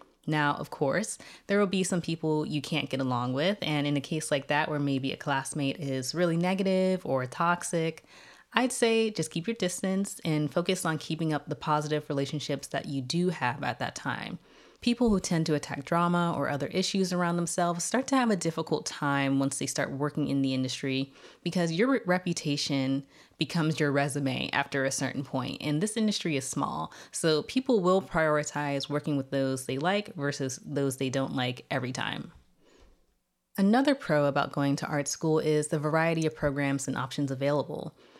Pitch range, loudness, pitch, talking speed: 140-175 Hz, -29 LUFS, 150 Hz, 185 wpm